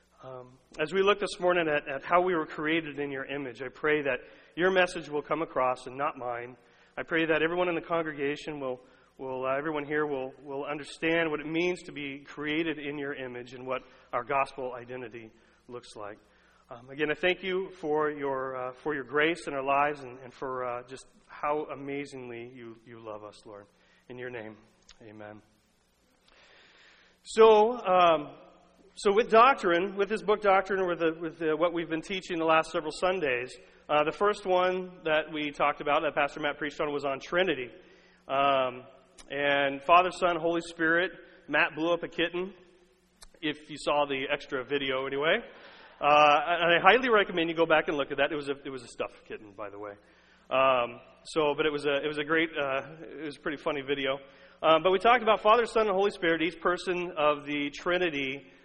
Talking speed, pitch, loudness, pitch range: 200 wpm, 150 Hz, -28 LUFS, 135-175 Hz